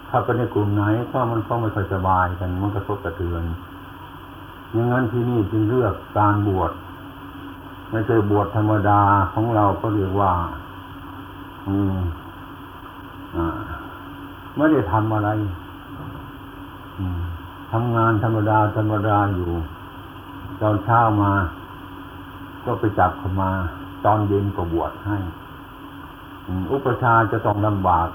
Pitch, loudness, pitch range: 100 Hz, -21 LUFS, 95-110 Hz